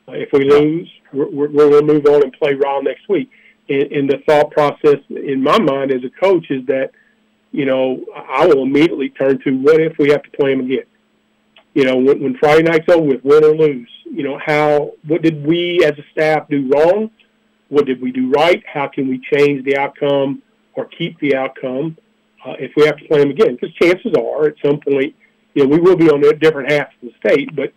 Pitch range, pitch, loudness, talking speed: 140-155 Hz, 145 Hz, -14 LUFS, 230 wpm